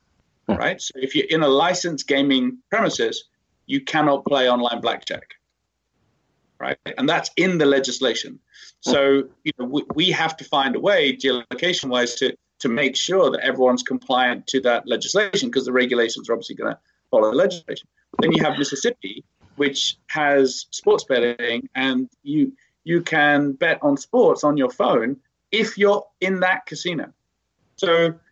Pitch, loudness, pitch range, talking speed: 155 Hz, -20 LUFS, 130-205 Hz, 160 wpm